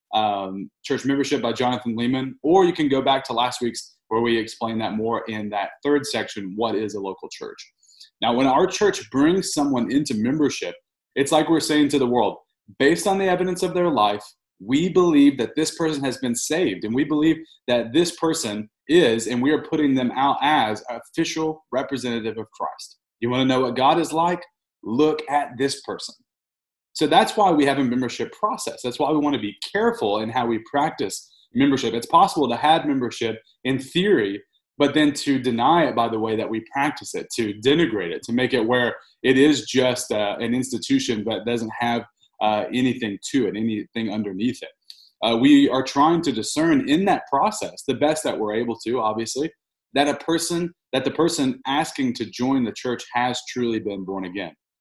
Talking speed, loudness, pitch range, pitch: 200 wpm, -22 LUFS, 115-155 Hz, 130 Hz